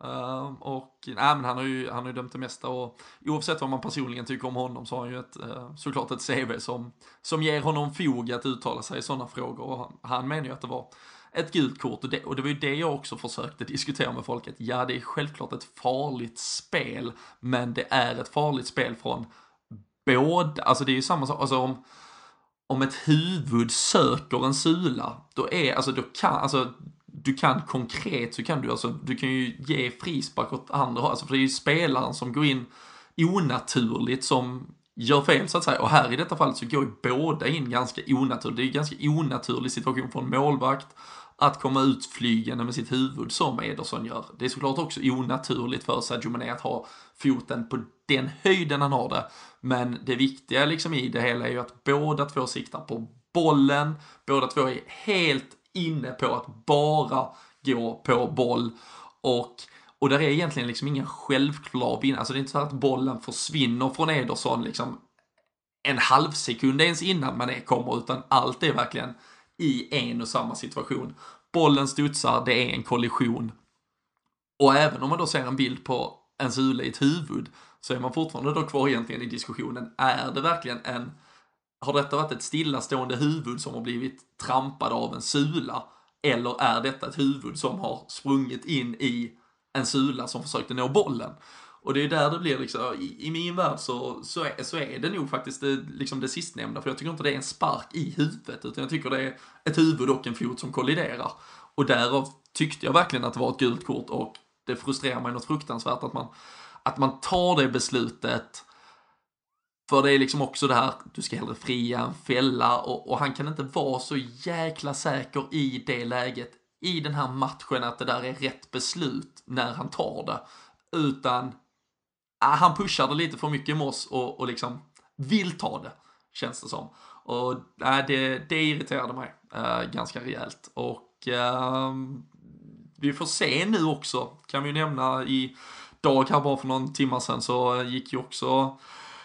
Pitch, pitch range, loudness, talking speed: 135 Hz, 125-145 Hz, -27 LUFS, 195 wpm